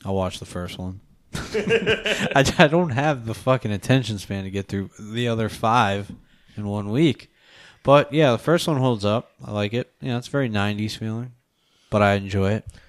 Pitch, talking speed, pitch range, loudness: 115 Hz, 185 wpm, 100-135 Hz, -22 LUFS